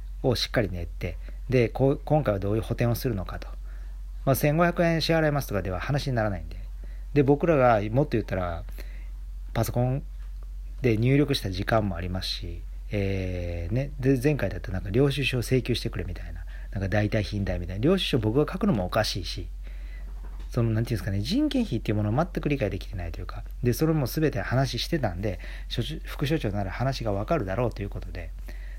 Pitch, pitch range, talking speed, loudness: 105 Hz, 90-135 Hz, 405 characters per minute, -27 LUFS